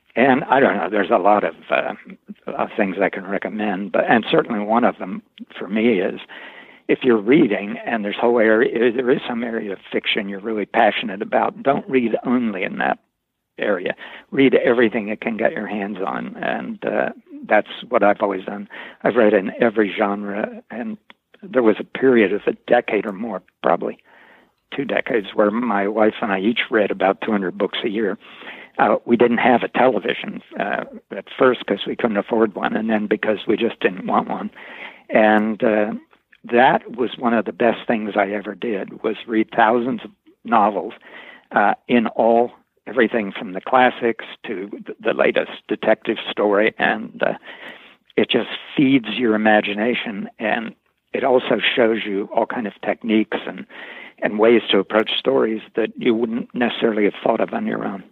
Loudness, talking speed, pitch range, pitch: -19 LUFS, 185 wpm, 105-130 Hz, 115 Hz